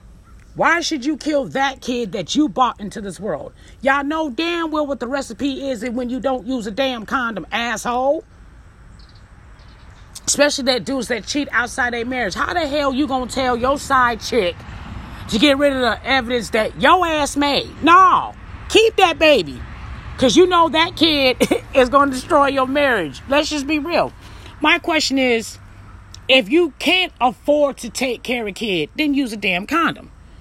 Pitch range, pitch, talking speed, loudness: 245-300 Hz, 270 Hz, 180 wpm, -17 LUFS